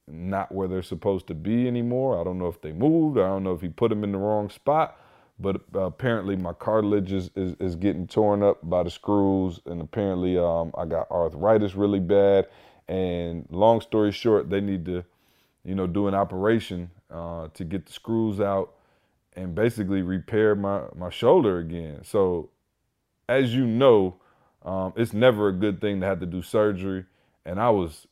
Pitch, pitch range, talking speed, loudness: 95 Hz, 90-105 Hz, 190 wpm, -25 LUFS